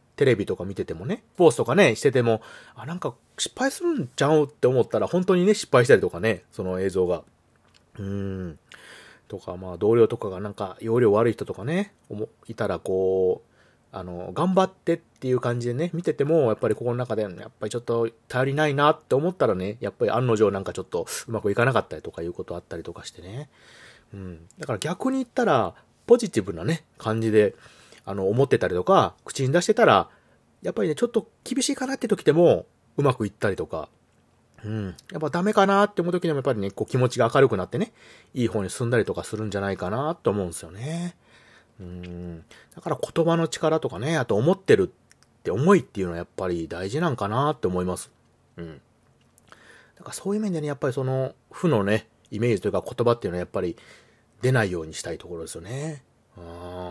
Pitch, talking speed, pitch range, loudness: 120 Hz, 420 characters per minute, 100-160 Hz, -24 LUFS